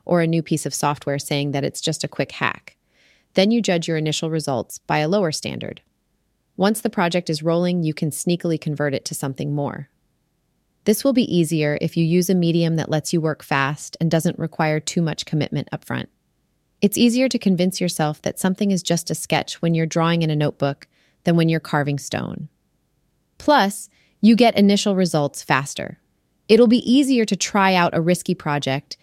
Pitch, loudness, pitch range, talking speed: 165 Hz, -20 LUFS, 150-185 Hz, 195 wpm